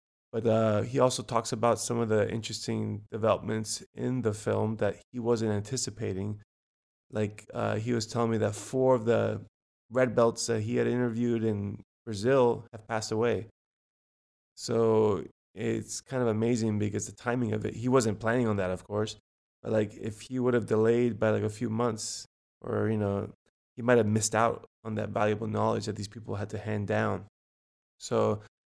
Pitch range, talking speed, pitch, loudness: 105-120 Hz, 185 wpm, 110 Hz, -29 LUFS